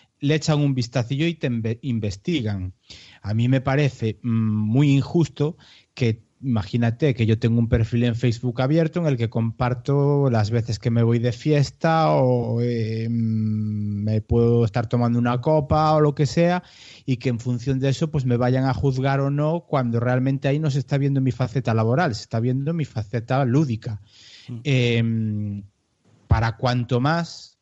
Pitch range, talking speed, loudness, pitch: 115-140 Hz, 170 wpm, -22 LUFS, 125 Hz